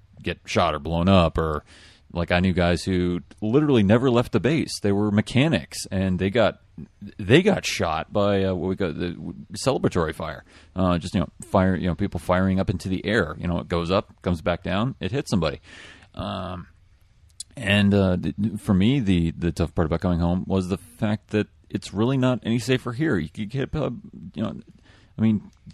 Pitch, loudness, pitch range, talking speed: 95 Hz, -23 LUFS, 90-105 Hz, 205 wpm